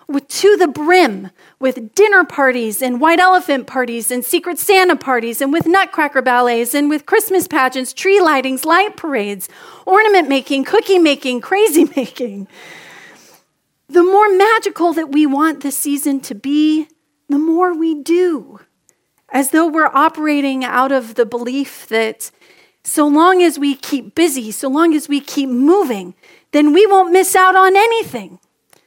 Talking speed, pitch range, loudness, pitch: 155 wpm, 260-360 Hz, -14 LUFS, 300 Hz